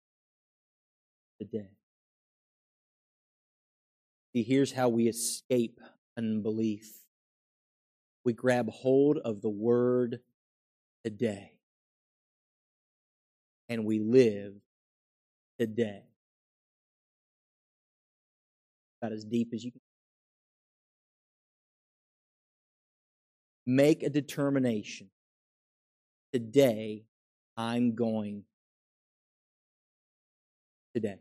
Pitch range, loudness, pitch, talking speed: 110-125 Hz, -30 LUFS, 115 Hz, 60 wpm